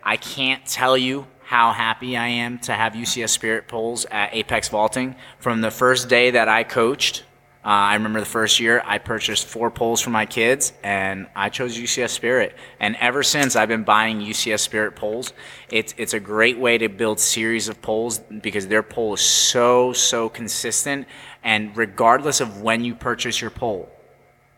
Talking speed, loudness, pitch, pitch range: 185 wpm, -20 LUFS, 115 Hz, 110-120 Hz